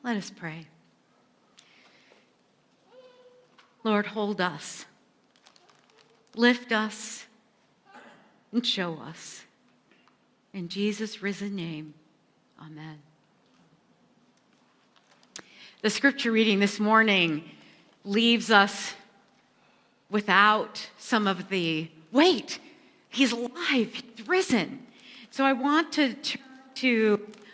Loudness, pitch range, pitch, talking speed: -26 LUFS, 200-245 Hz, 220 Hz, 85 wpm